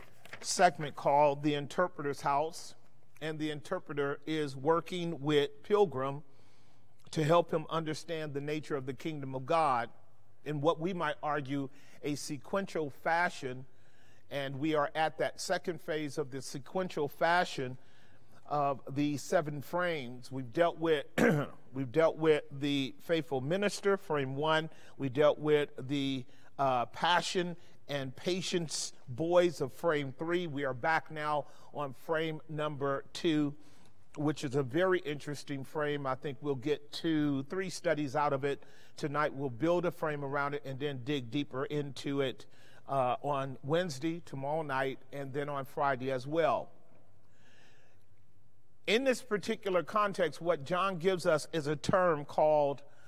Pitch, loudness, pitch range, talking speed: 145 Hz, -33 LUFS, 135-165 Hz, 145 wpm